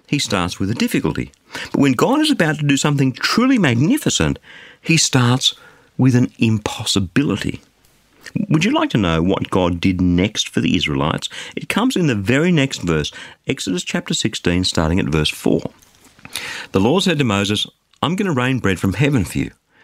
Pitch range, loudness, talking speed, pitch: 95-155 Hz, -18 LUFS, 180 wpm, 125 Hz